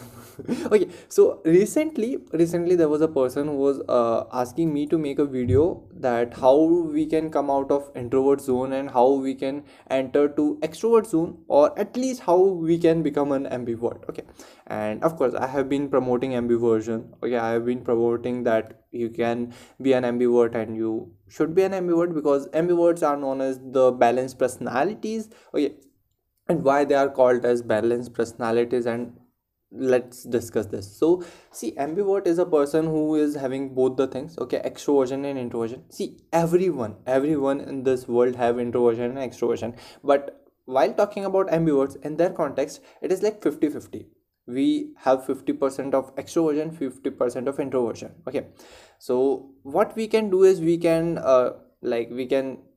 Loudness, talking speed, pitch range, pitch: -23 LUFS, 175 wpm, 125-165 Hz, 135 Hz